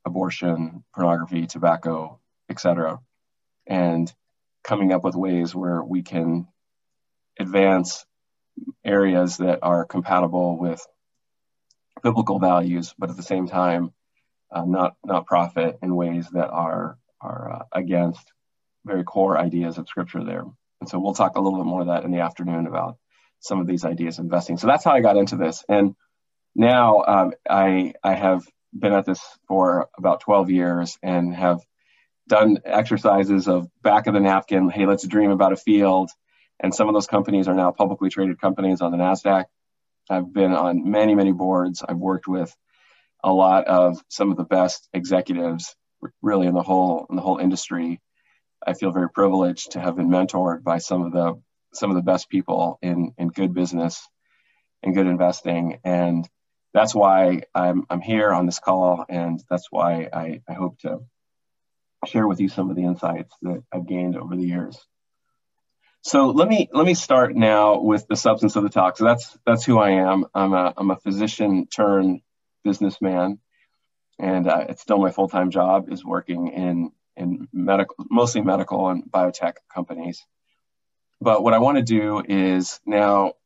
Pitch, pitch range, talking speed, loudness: 90 Hz, 85-95 Hz, 170 wpm, -21 LUFS